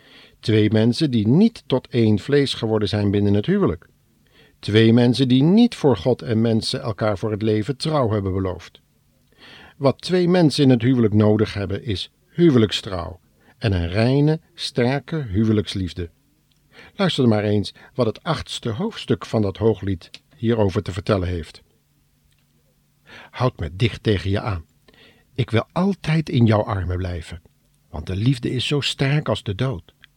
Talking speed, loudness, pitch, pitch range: 155 wpm, -20 LUFS, 110 Hz, 100-135 Hz